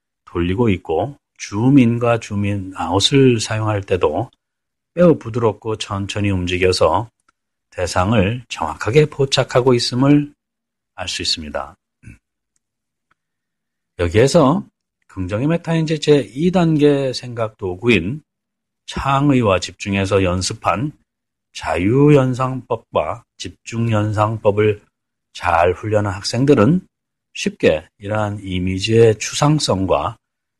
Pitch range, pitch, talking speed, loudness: 100-135 Hz, 115 Hz, 220 characters per minute, -17 LUFS